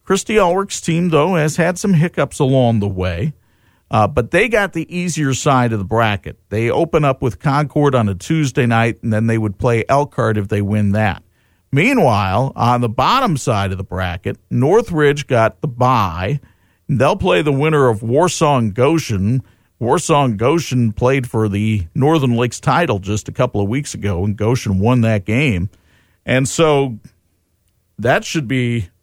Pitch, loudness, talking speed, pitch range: 120 Hz, -16 LUFS, 175 wpm, 105-145 Hz